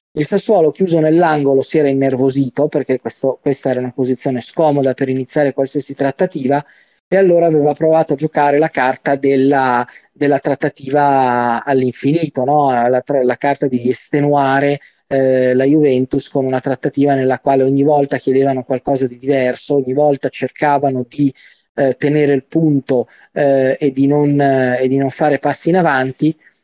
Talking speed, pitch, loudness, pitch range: 160 wpm, 140 Hz, -14 LUFS, 130-145 Hz